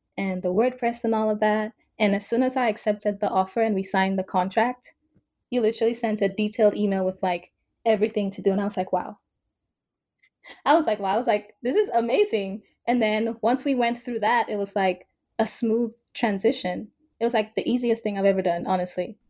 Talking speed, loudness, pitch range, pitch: 215 wpm, -24 LUFS, 195-235 Hz, 215 Hz